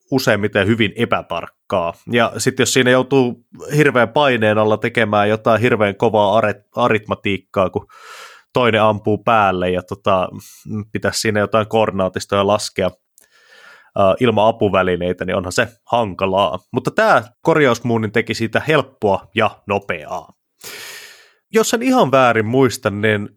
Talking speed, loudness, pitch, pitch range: 125 wpm, -17 LUFS, 110 Hz, 105-130 Hz